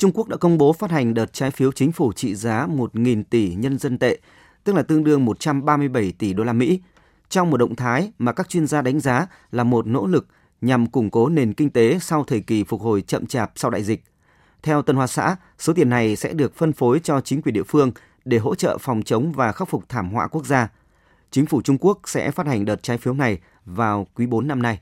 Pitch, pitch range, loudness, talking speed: 130 Hz, 115-150 Hz, -21 LUFS, 245 wpm